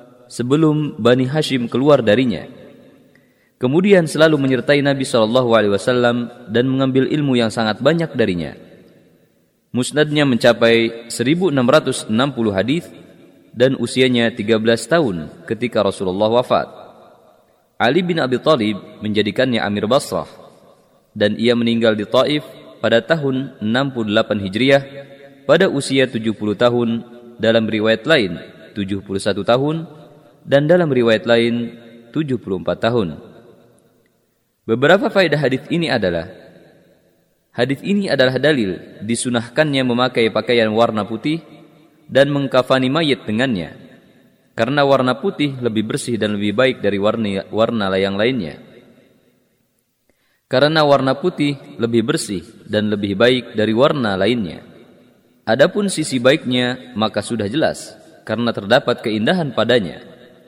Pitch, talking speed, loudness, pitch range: 120 Hz, 110 wpm, -17 LUFS, 110-140 Hz